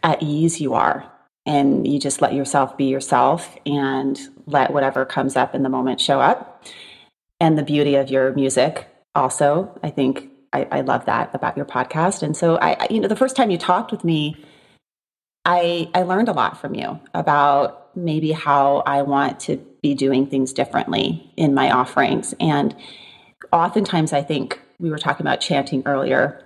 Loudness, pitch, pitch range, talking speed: -19 LUFS, 145 Hz, 140-165 Hz, 180 wpm